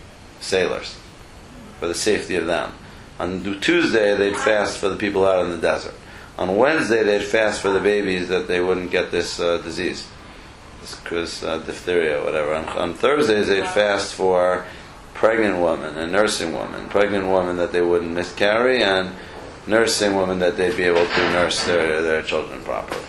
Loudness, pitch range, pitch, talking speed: -20 LUFS, 90-100 Hz, 95 Hz, 170 wpm